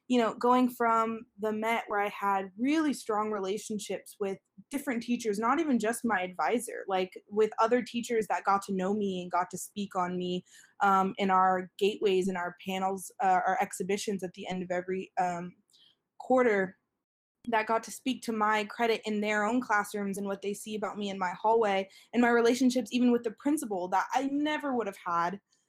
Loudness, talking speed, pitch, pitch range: -30 LUFS, 200 wpm, 210 Hz, 190-235 Hz